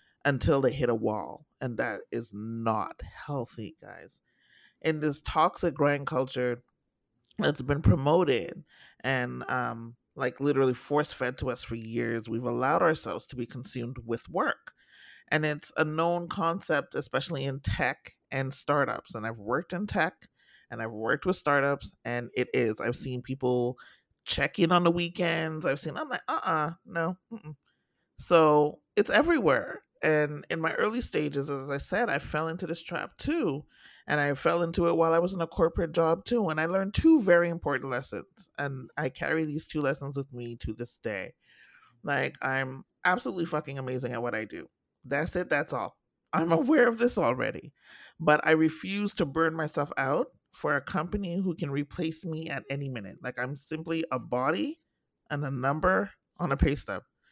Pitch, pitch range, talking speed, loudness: 150 Hz, 125-170 Hz, 175 wpm, -29 LUFS